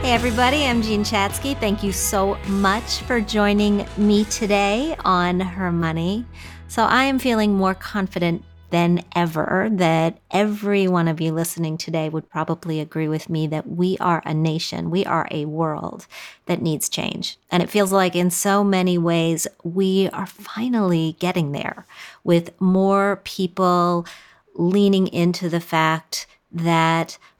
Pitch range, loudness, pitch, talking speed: 165-200 Hz, -20 LUFS, 180 Hz, 150 wpm